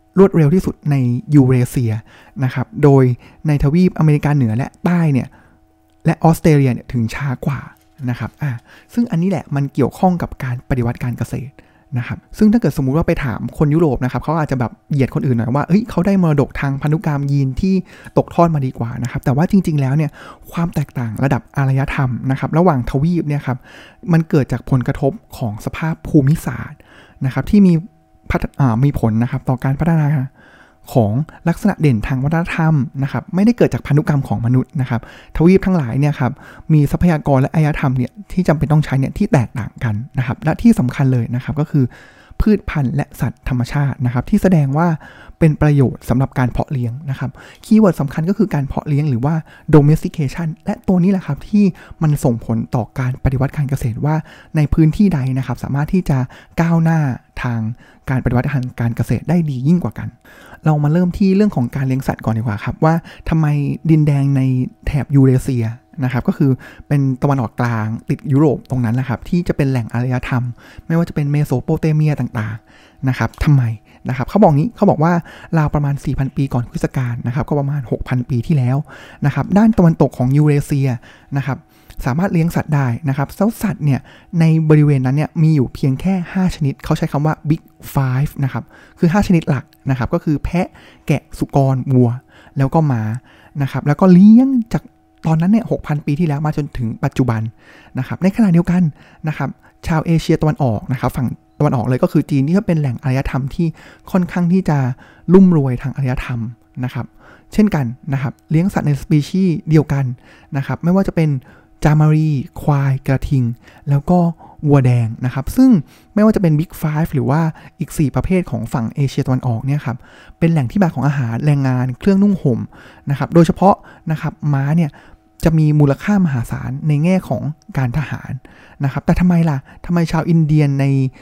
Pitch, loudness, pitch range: 140 Hz, -16 LUFS, 125-165 Hz